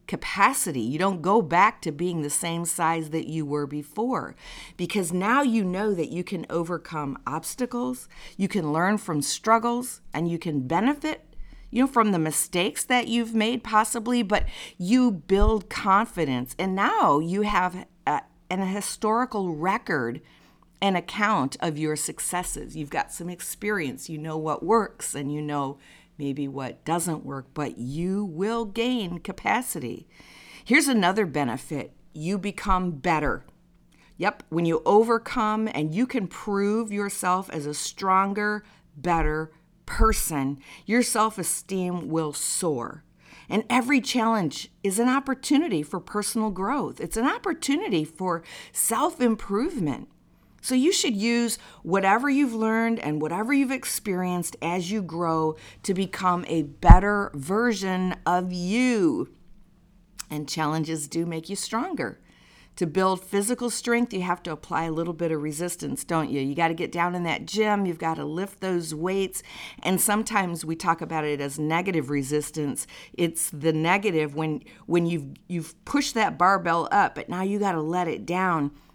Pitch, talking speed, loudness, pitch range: 180 Hz, 155 wpm, -25 LUFS, 160-215 Hz